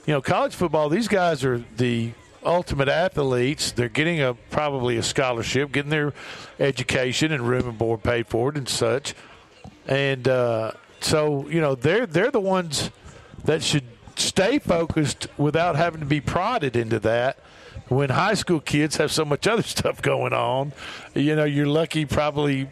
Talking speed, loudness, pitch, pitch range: 170 wpm, -23 LUFS, 145 Hz, 125-155 Hz